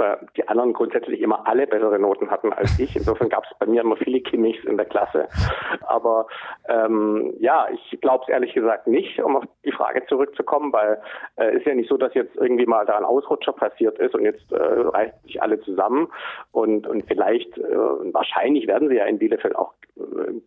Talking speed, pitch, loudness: 205 wpm, 380 Hz, -21 LUFS